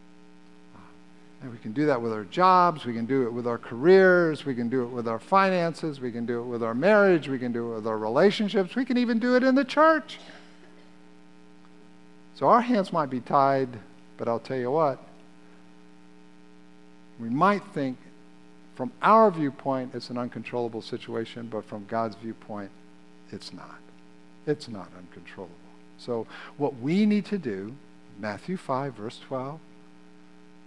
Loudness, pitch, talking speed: -25 LUFS, 115 Hz, 165 wpm